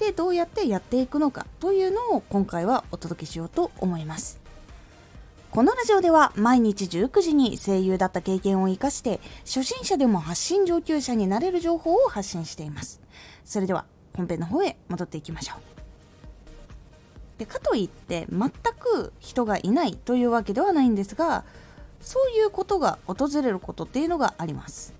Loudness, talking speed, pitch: -25 LUFS, 350 characters per minute, 245 Hz